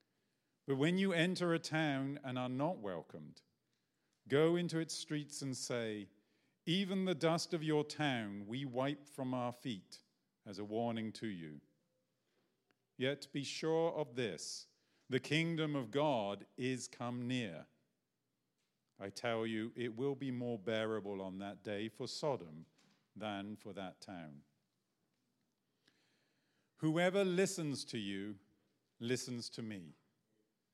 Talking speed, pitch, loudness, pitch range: 135 wpm, 125 Hz, -40 LUFS, 105-150 Hz